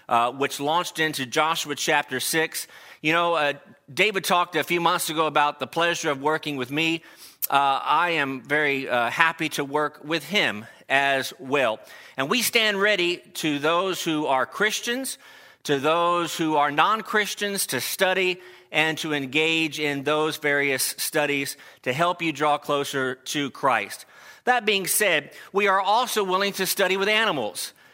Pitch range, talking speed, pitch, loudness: 145-185 Hz, 165 wpm, 160 Hz, -23 LUFS